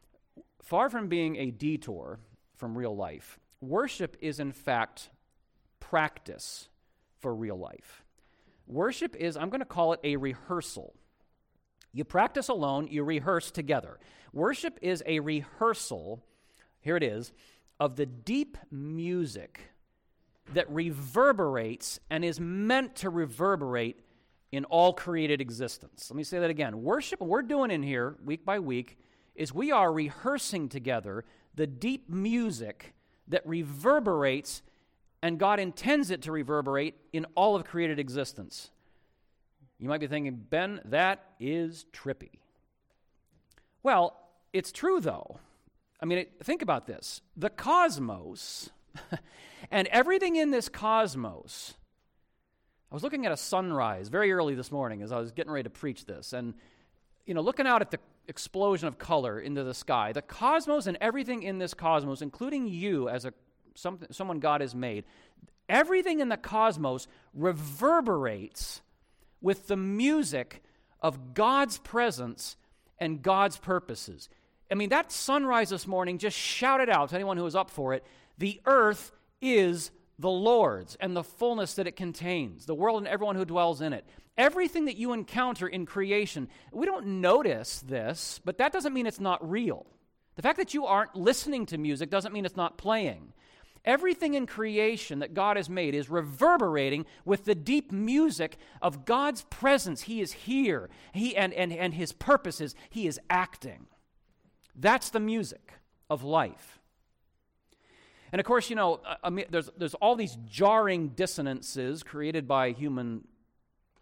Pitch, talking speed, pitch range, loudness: 175 Hz, 150 wpm, 145-220 Hz, -30 LUFS